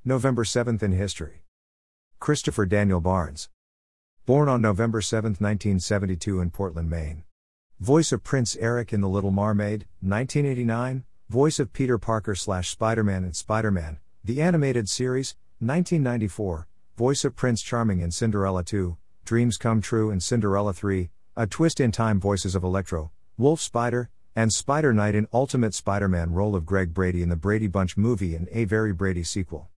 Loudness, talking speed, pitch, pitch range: -25 LUFS, 160 wpm, 105 Hz, 90-120 Hz